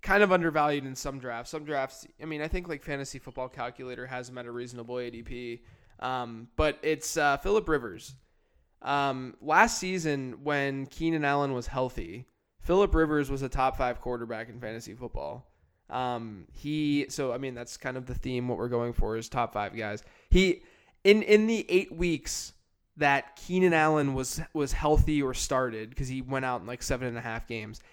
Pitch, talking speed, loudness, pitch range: 130 Hz, 190 wpm, -29 LUFS, 120-150 Hz